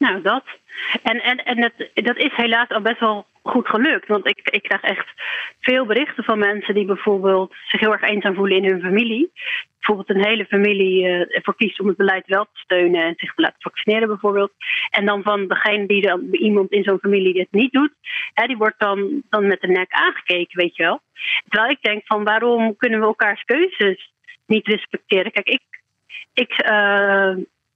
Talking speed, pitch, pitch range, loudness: 200 wpm, 210 Hz, 195-230 Hz, -18 LUFS